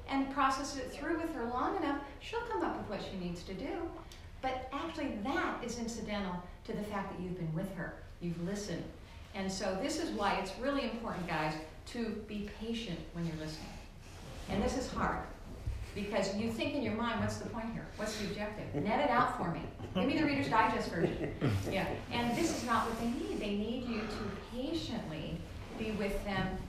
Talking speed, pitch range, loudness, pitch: 205 wpm, 195-275 Hz, -37 LUFS, 220 Hz